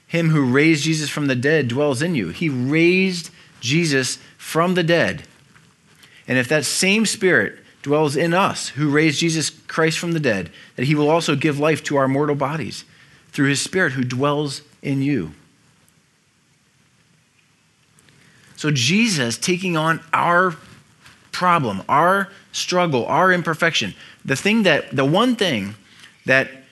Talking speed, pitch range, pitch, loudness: 145 wpm, 140-170 Hz, 155 Hz, -19 LUFS